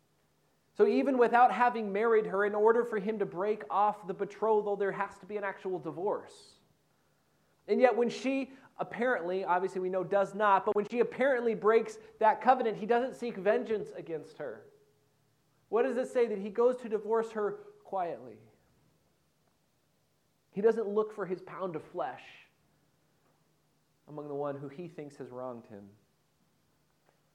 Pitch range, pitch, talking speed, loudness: 190-235 Hz, 210 Hz, 160 wpm, -31 LUFS